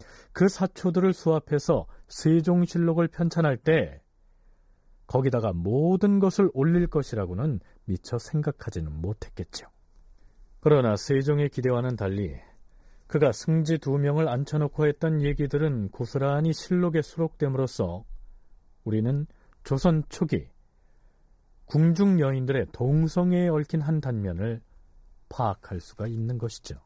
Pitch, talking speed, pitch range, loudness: 140 Hz, 265 characters per minute, 105-160 Hz, -26 LUFS